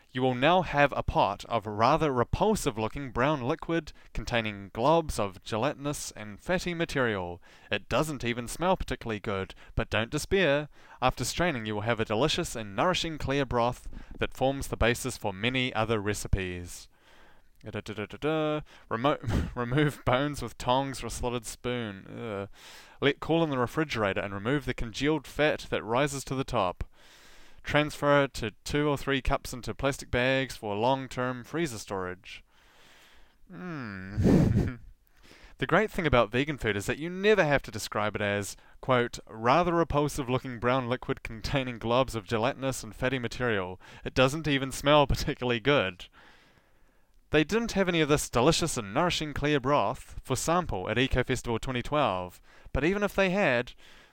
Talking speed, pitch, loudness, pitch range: 160 wpm, 125 Hz, -29 LUFS, 110-145 Hz